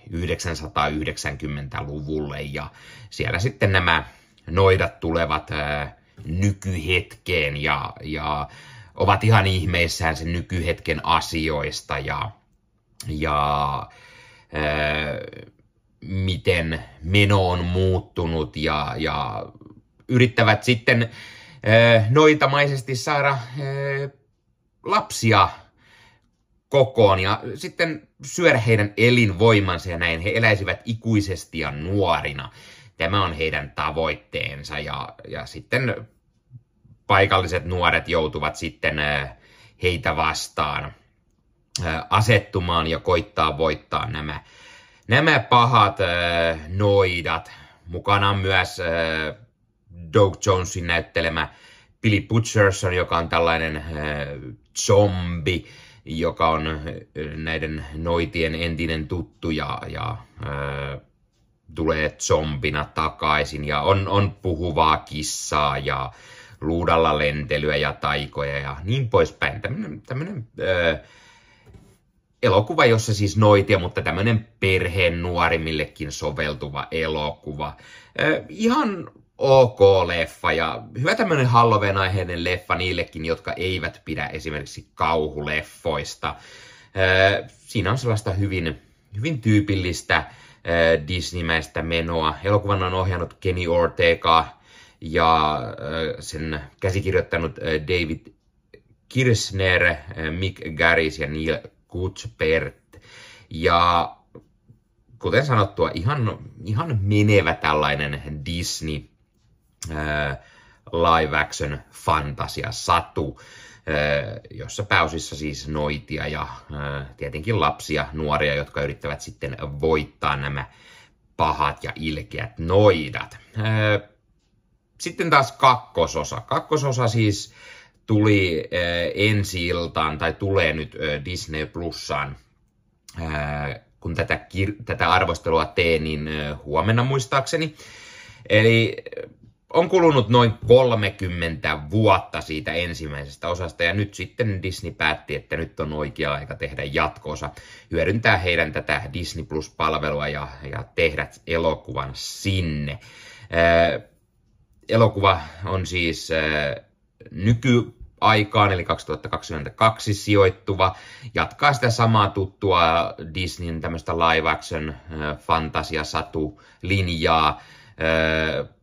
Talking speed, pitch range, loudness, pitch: 90 wpm, 75-105 Hz, -22 LUFS, 85 Hz